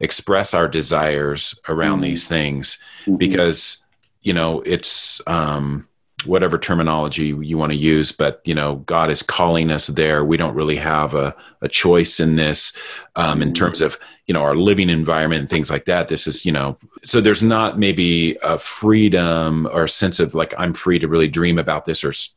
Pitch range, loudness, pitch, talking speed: 75-85 Hz, -17 LUFS, 80 Hz, 190 wpm